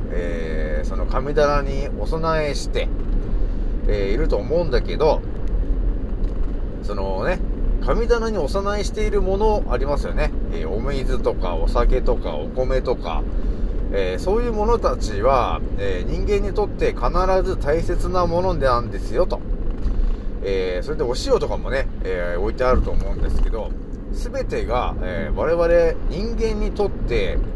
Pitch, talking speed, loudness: 155 Hz, 275 characters per minute, -23 LUFS